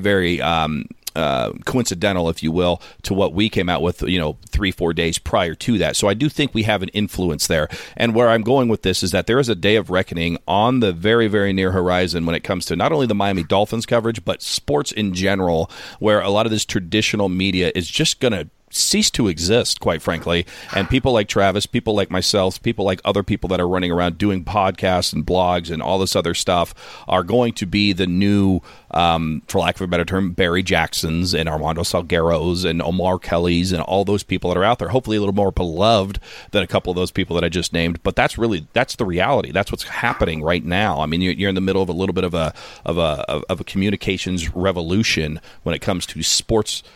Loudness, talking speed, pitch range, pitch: -19 LUFS, 235 wpm, 85-105 Hz, 95 Hz